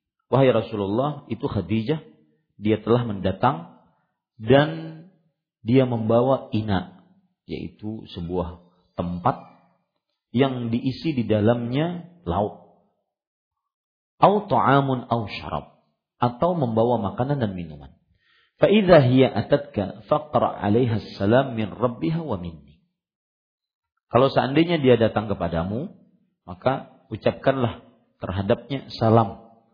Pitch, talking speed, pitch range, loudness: 115 Hz, 75 wpm, 100-140 Hz, -22 LUFS